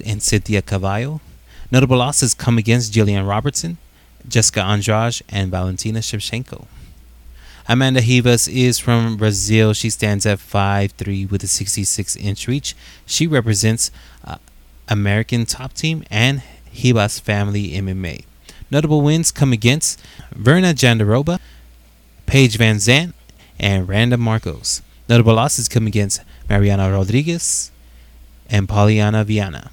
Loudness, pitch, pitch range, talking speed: -17 LUFS, 110 Hz, 100-125 Hz, 120 wpm